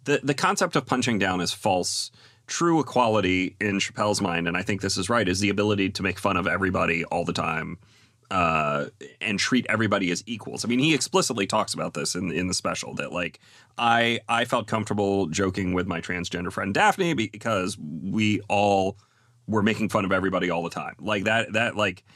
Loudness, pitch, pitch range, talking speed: -25 LUFS, 105 Hz, 95-120 Hz, 200 wpm